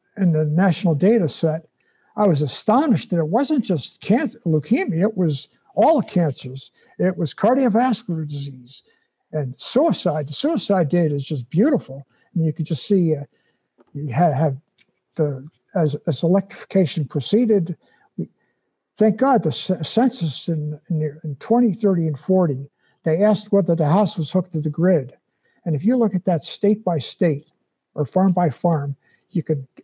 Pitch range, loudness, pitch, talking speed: 155-200 Hz, -20 LUFS, 170 Hz, 165 wpm